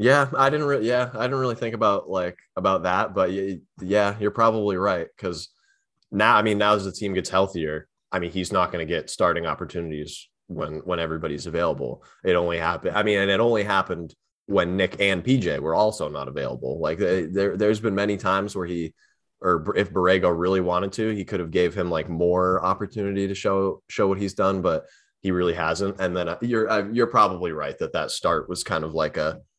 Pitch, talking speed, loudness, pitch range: 95 Hz, 215 wpm, -24 LUFS, 90-105 Hz